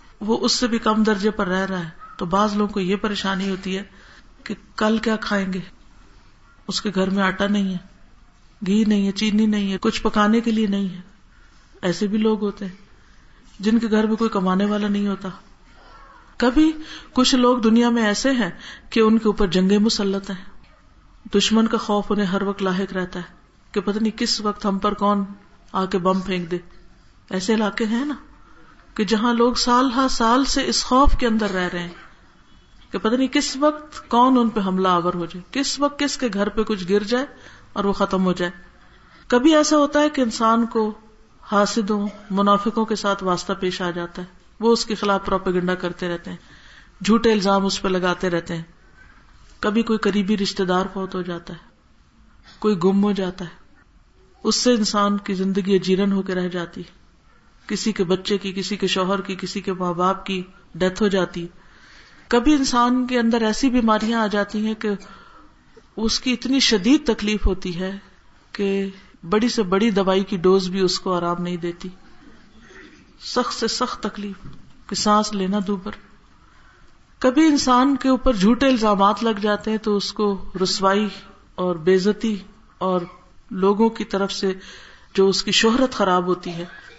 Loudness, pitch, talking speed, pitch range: -20 LUFS, 205 Hz, 190 wpm, 190-225 Hz